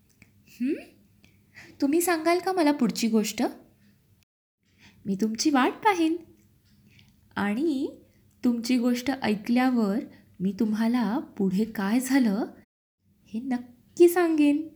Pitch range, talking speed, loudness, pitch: 225-315 Hz, 95 wpm, -26 LUFS, 255 Hz